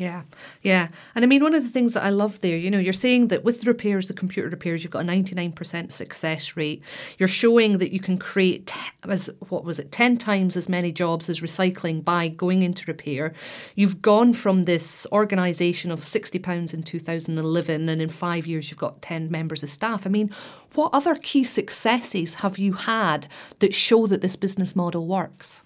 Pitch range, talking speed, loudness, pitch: 170-205 Hz, 200 wpm, -23 LUFS, 185 Hz